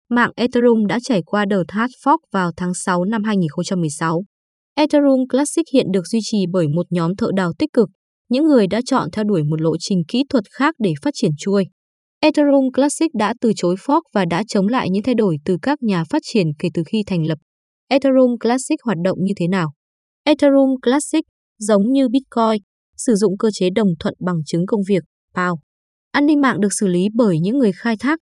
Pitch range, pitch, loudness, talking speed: 185-260 Hz, 215 Hz, -18 LUFS, 210 wpm